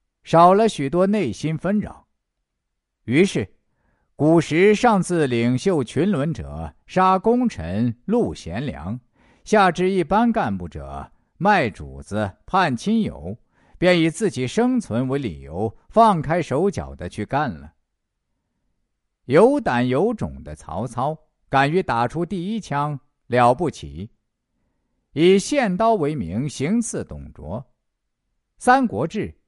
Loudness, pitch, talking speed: -20 LUFS, 145 Hz, 170 characters per minute